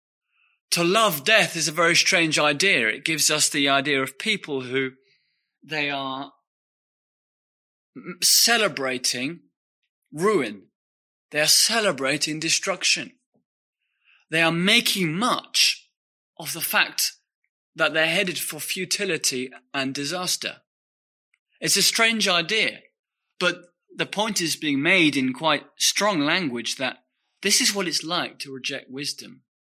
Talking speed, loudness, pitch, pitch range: 125 wpm, -21 LUFS, 165 Hz, 140-200 Hz